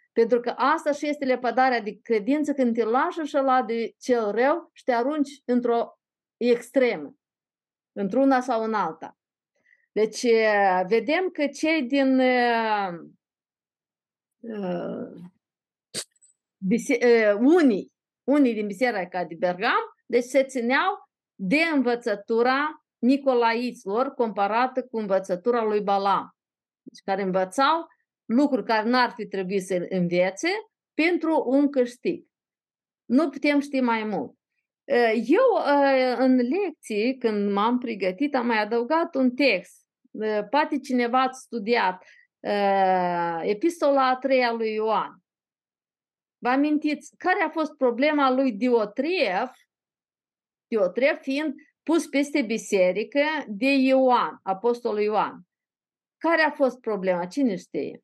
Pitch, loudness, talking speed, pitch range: 250 Hz, -24 LUFS, 115 wpm, 220-285 Hz